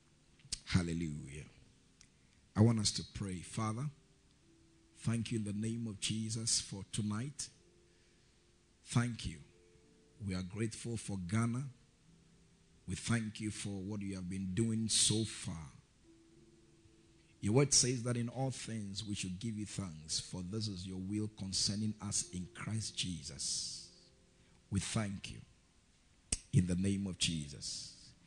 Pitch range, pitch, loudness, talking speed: 90-115 Hz, 105 Hz, -37 LUFS, 135 wpm